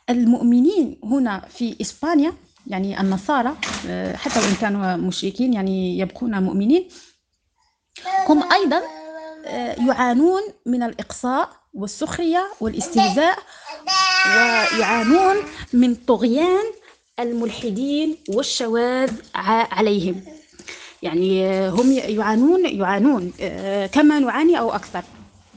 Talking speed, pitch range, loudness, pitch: 80 wpm, 210-315 Hz, -19 LUFS, 250 Hz